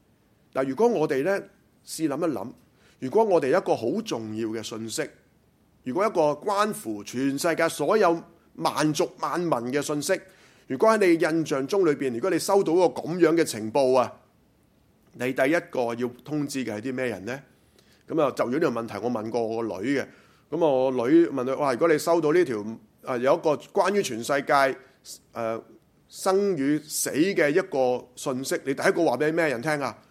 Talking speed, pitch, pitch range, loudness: 260 characters per minute, 145 Hz, 125-170 Hz, -25 LUFS